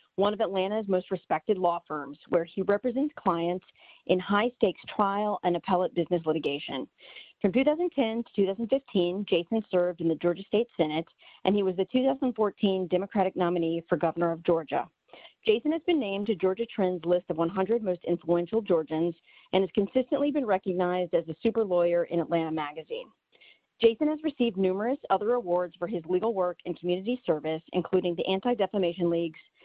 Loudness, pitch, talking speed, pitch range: -28 LUFS, 185 Hz, 170 wpm, 175-225 Hz